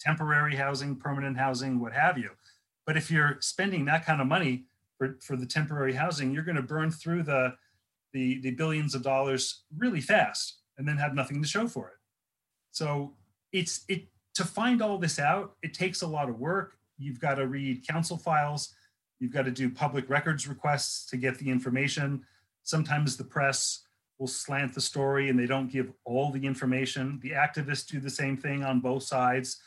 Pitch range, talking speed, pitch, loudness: 130-155 Hz, 190 wpm, 140 Hz, -30 LUFS